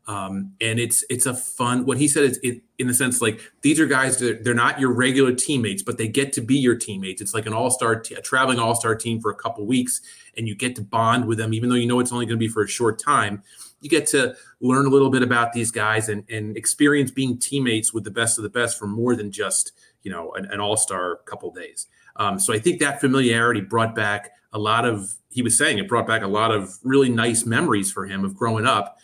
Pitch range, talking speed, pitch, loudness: 110-130 Hz, 260 wpm, 120 Hz, -21 LUFS